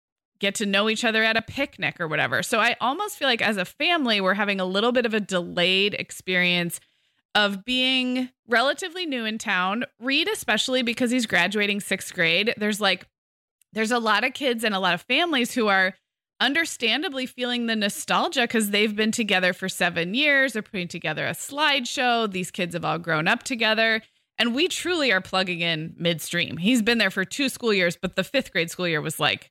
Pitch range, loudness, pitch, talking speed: 185-250 Hz, -23 LUFS, 215 Hz, 200 wpm